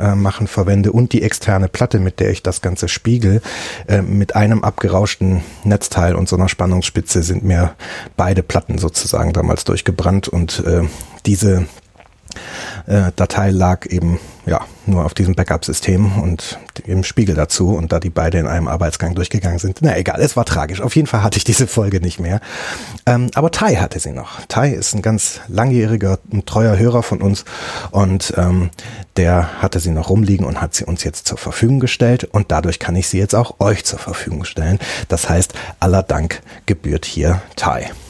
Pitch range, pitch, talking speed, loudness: 90-105 Hz, 95 Hz, 180 wpm, -16 LUFS